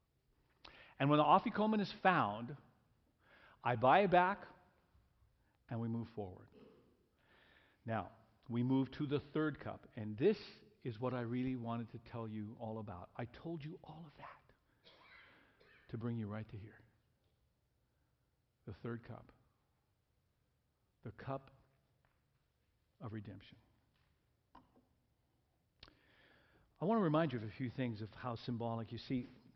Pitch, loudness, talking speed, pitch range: 120 Hz, -39 LUFS, 135 wpm, 110-140 Hz